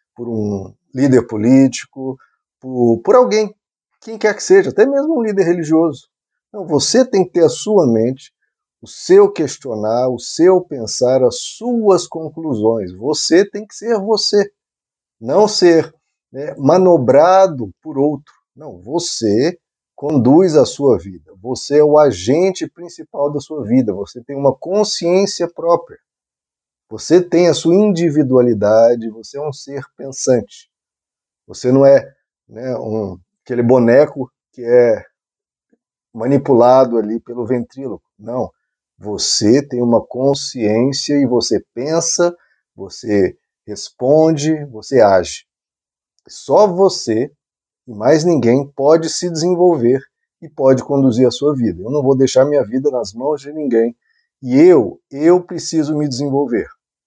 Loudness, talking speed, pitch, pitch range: -14 LUFS, 135 wpm, 145 Hz, 125-180 Hz